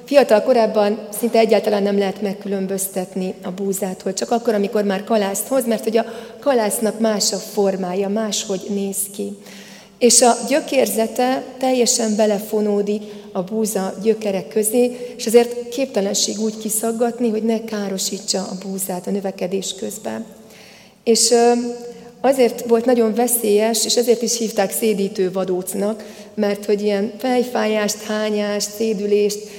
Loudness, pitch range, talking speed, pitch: -19 LUFS, 200-230 Hz, 130 wpm, 215 Hz